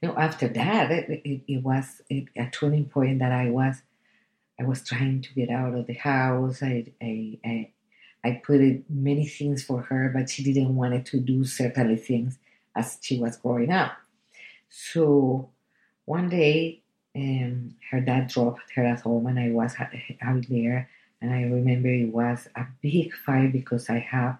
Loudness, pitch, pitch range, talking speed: -26 LUFS, 130 Hz, 120-135 Hz, 175 wpm